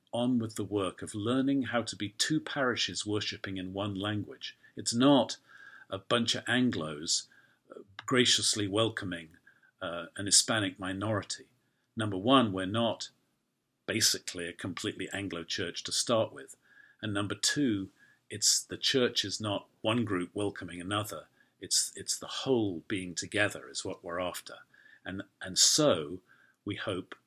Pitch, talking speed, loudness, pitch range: 105 Hz, 145 wpm, -30 LUFS, 95-120 Hz